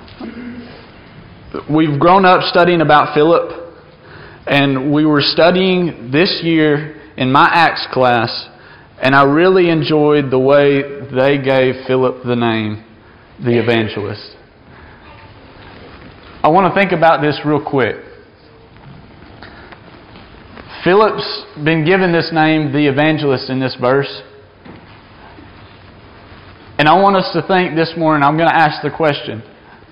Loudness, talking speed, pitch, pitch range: -13 LUFS, 120 wpm, 145 Hz, 120-160 Hz